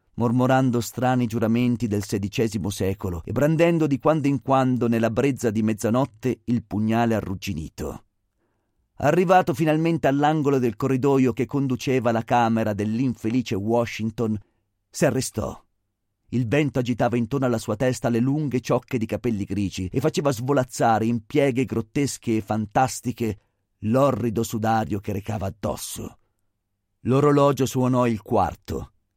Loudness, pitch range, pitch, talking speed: -23 LUFS, 110-130 Hz, 120 Hz, 130 wpm